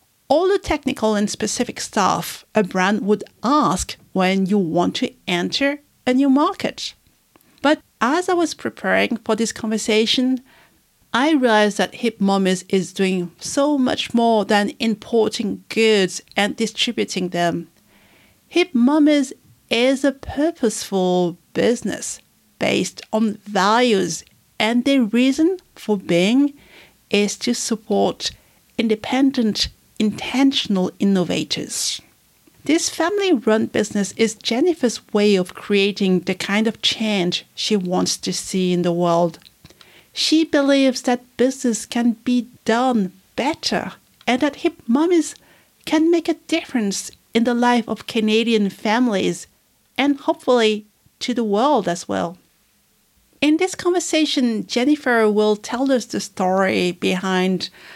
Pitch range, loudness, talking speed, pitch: 200-270 Hz, -19 LUFS, 125 wpm, 225 Hz